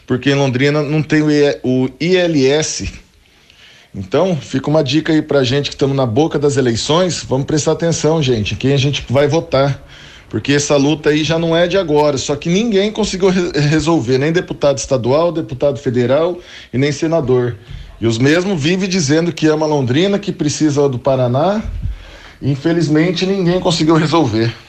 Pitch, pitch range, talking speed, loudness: 150 Hz, 130-165 Hz, 170 wpm, -15 LUFS